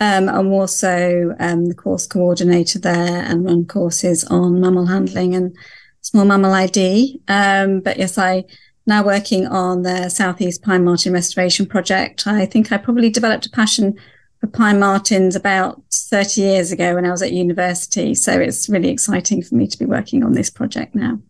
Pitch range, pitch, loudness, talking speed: 180-205 Hz, 190 Hz, -16 LUFS, 175 wpm